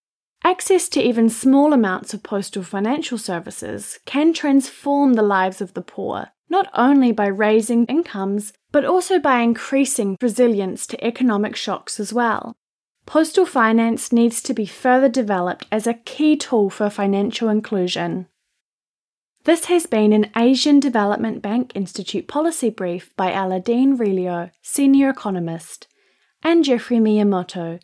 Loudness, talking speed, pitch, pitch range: -19 LUFS, 135 wpm, 230 Hz, 205-275 Hz